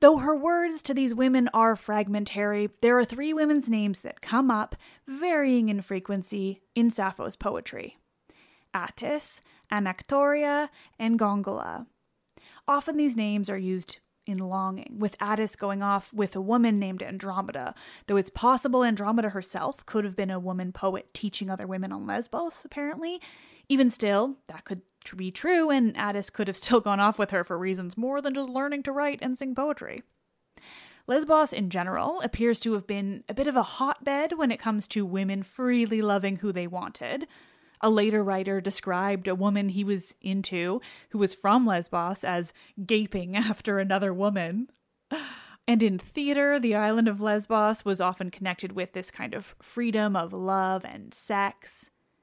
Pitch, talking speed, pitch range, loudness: 210 Hz, 165 wpm, 195-260 Hz, -27 LUFS